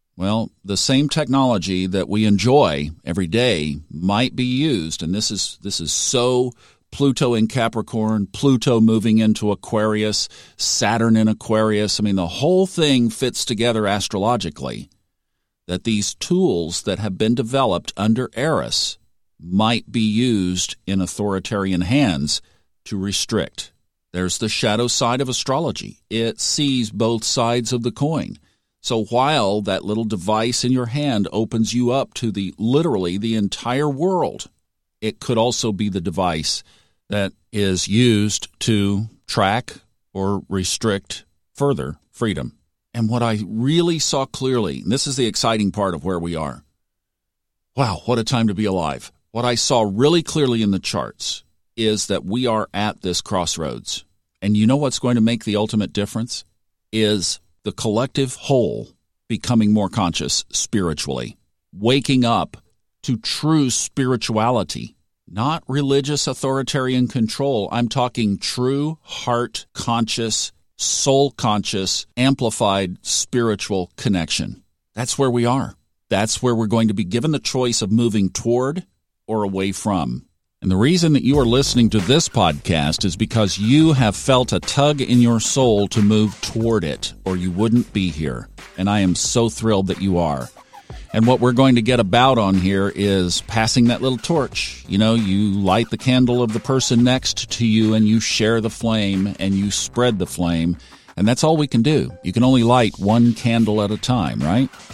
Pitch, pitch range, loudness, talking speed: 110 Hz, 95-125 Hz, -19 LUFS, 160 wpm